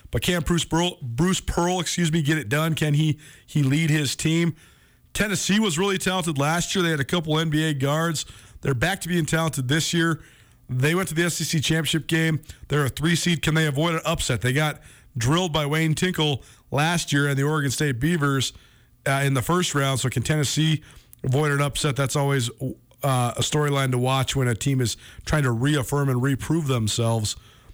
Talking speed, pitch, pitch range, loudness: 200 wpm, 150 Hz, 135-165 Hz, -23 LUFS